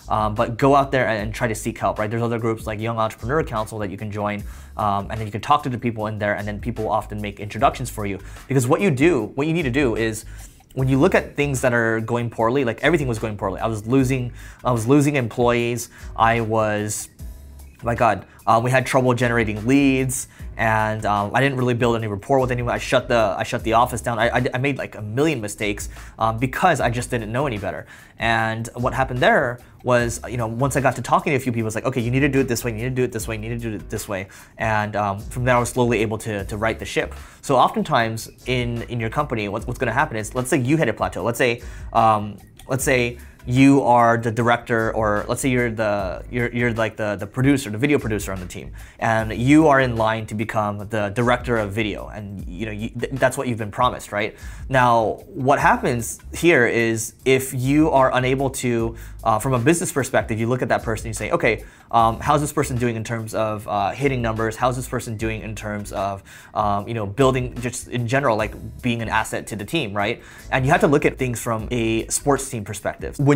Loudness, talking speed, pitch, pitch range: -21 LUFS, 250 wpm, 115 Hz, 110-130 Hz